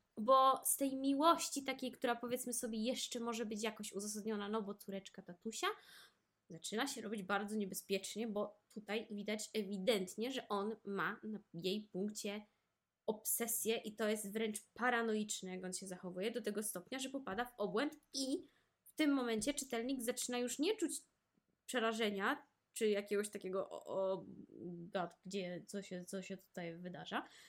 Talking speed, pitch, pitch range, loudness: 155 wpm, 215 Hz, 200-245 Hz, -40 LUFS